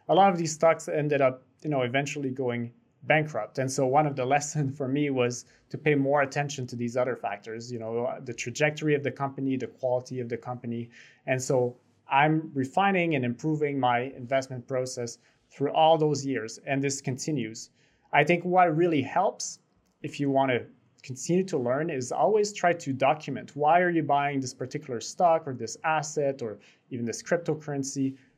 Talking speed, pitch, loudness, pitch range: 185 wpm, 135 Hz, -27 LUFS, 125-150 Hz